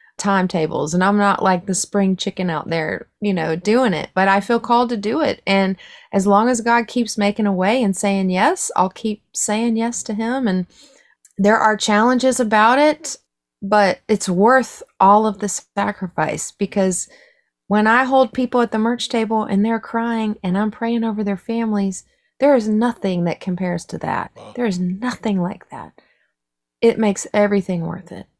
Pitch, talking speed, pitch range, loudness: 210 Hz, 185 wpm, 190-235 Hz, -18 LUFS